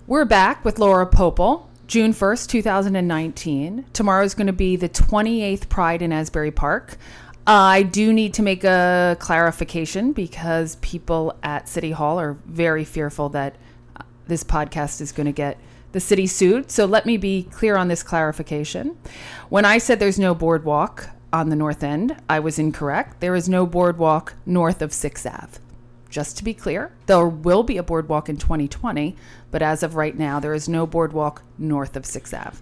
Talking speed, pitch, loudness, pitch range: 180 wpm, 165 Hz, -20 LUFS, 150-195 Hz